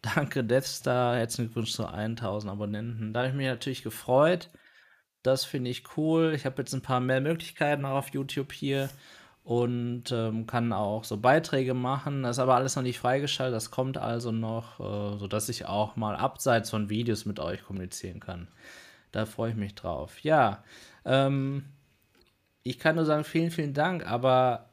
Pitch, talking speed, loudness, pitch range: 125 Hz, 175 wpm, -29 LUFS, 110-135 Hz